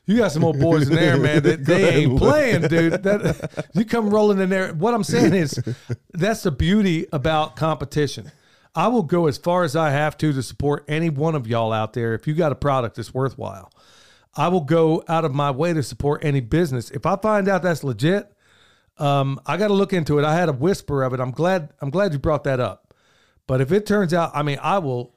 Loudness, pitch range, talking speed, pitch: -20 LUFS, 140-180 Hz, 235 wpm, 155 Hz